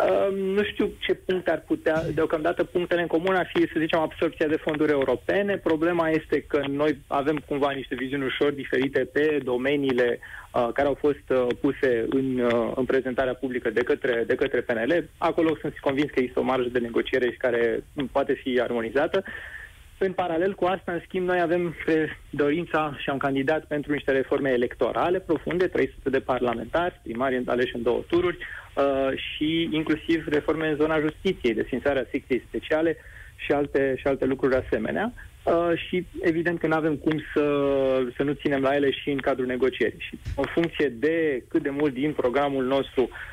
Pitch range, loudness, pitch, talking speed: 135-165 Hz, -25 LUFS, 145 Hz, 180 wpm